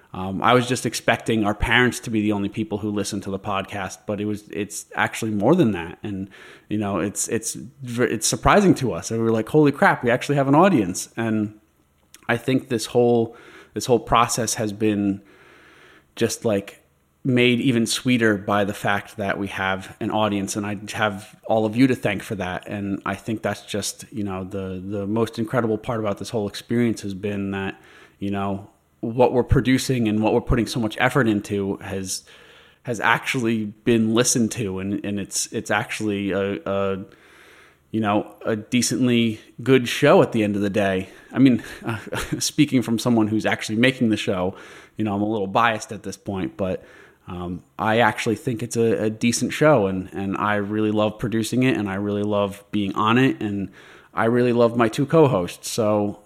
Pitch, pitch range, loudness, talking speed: 110 Hz, 100-120 Hz, -22 LUFS, 200 wpm